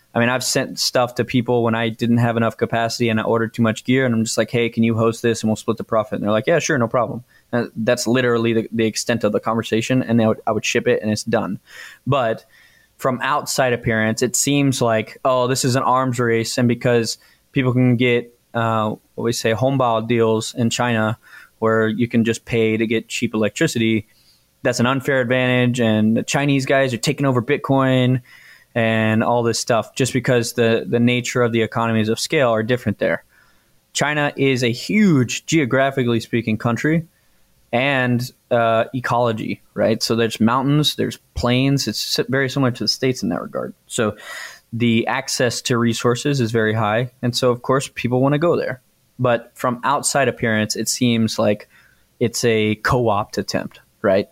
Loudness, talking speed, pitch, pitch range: -19 LUFS, 195 wpm, 120 Hz, 115-130 Hz